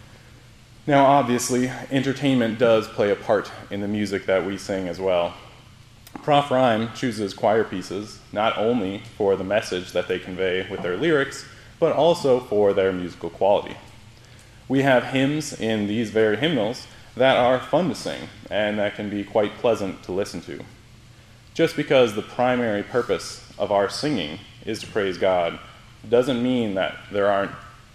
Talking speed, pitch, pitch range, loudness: 160 wpm, 115 Hz, 100-125 Hz, -22 LUFS